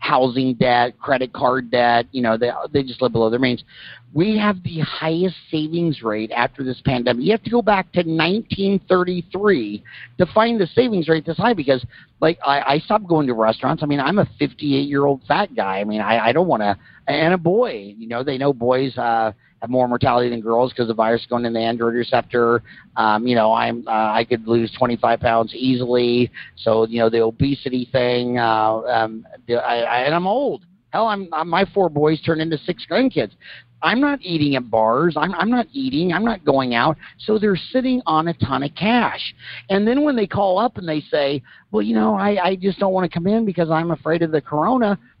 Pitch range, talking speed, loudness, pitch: 120-180 Hz, 220 wpm, -19 LUFS, 140 Hz